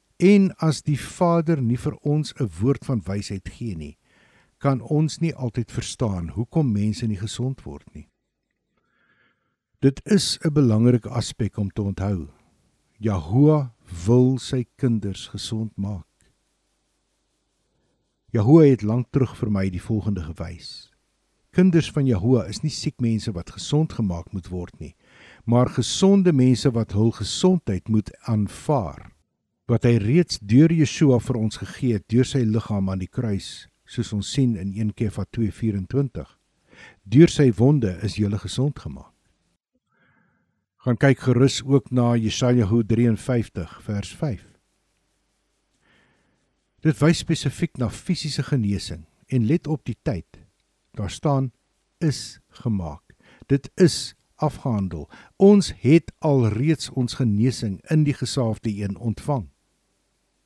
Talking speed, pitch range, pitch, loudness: 130 wpm, 105-140 Hz, 120 Hz, -22 LUFS